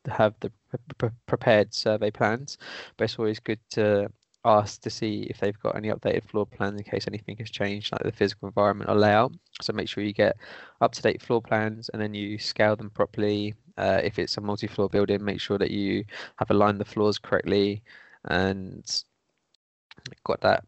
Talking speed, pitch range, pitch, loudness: 195 wpm, 100-110 Hz, 105 Hz, -26 LUFS